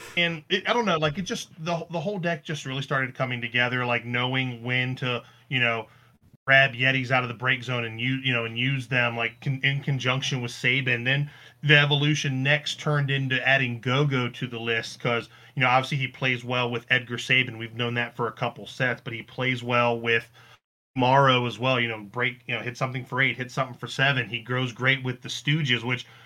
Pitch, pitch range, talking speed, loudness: 125 Hz, 120-135 Hz, 225 wpm, -25 LUFS